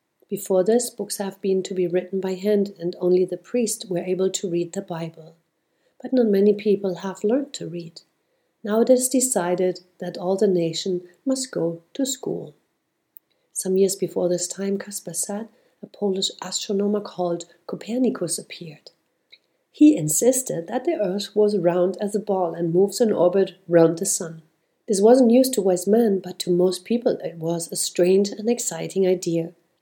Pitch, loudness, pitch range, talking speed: 190 Hz, -22 LUFS, 175-210 Hz, 175 wpm